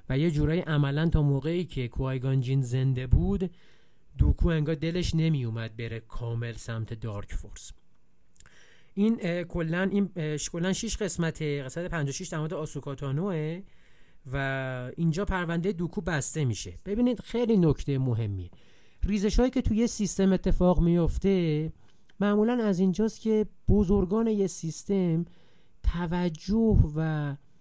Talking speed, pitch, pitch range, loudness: 125 wpm, 165 Hz, 135-190 Hz, -28 LUFS